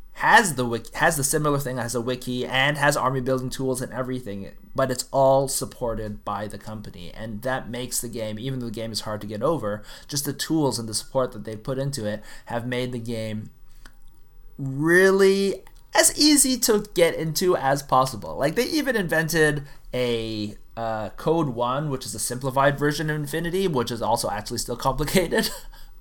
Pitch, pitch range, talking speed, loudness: 130 Hz, 115-150 Hz, 190 wpm, -23 LUFS